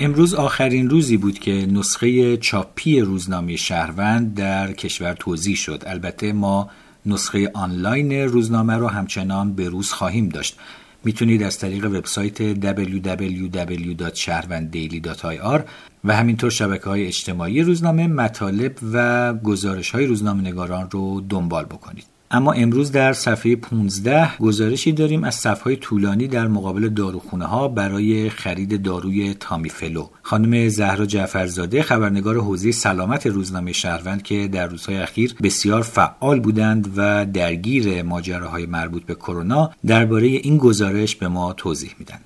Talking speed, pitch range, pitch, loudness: 125 wpm, 95-115 Hz, 100 Hz, -20 LUFS